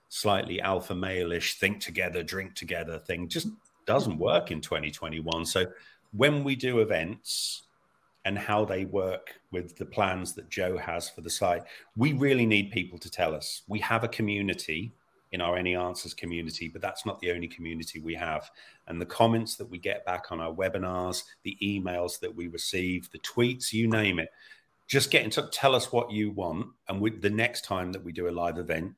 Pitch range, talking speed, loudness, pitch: 85-110 Hz, 195 wpm, -30 LUFS, 95 Hz